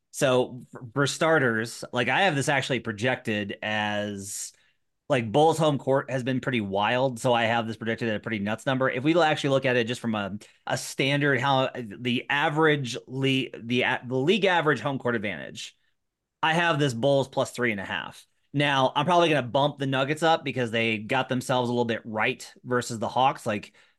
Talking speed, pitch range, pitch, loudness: 200 wpm, 115-140 Hz, 125 Hz, -25 LUFS